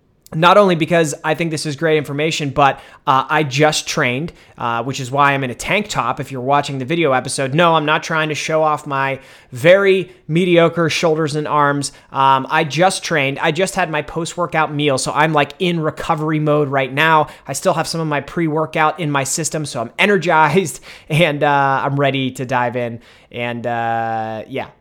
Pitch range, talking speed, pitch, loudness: 135-160 Hz, 205 wpm, 150 Hz, -16 LUFS